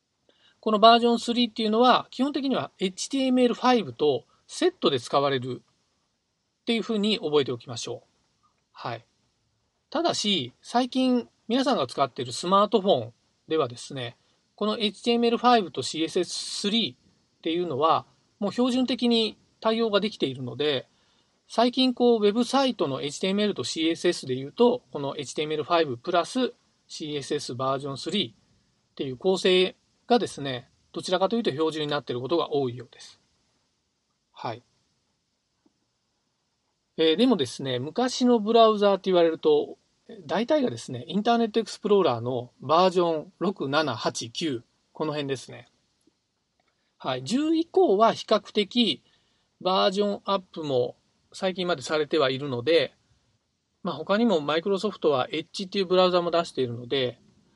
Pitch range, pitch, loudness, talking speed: 145-235 Hz, 190 Hz, -25 LUFS, 310 characters per minute